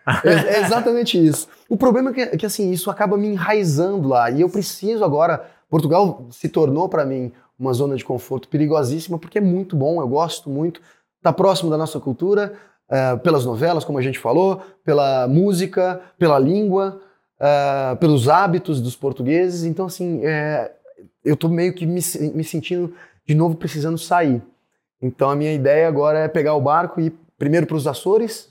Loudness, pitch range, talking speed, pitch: -19 LUFS, 145-185 Hz, 180 wpm, 165 Hz